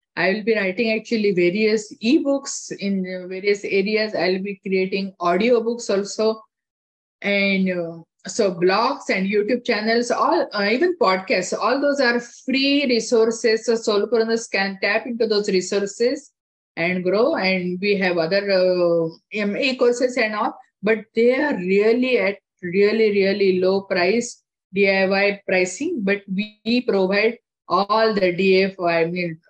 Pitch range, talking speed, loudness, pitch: 190-230 Hz, 140 wpm, -20 LUFS, 205 Hz